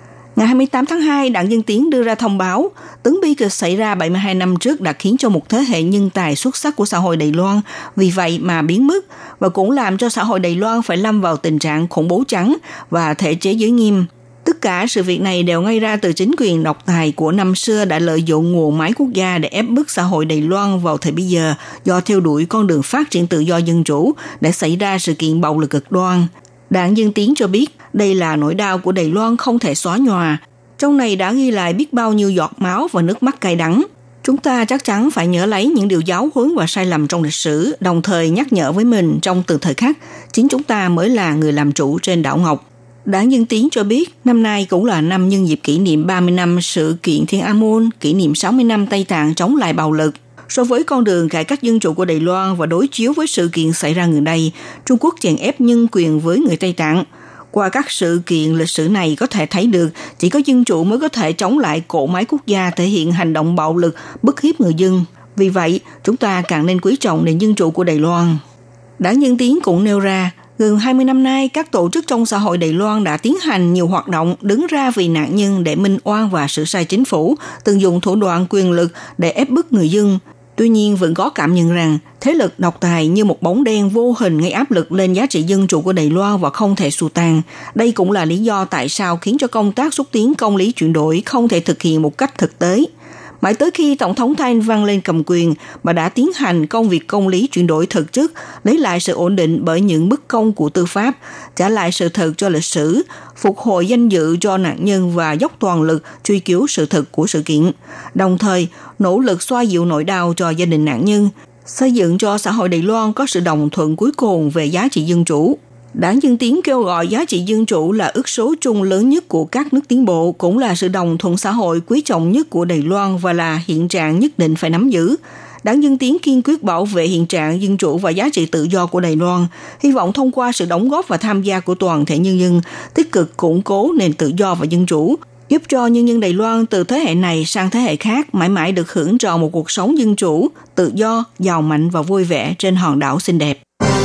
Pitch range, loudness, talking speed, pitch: 165-230 Hz, -15 LUFS, 255 wpm, 185 Hz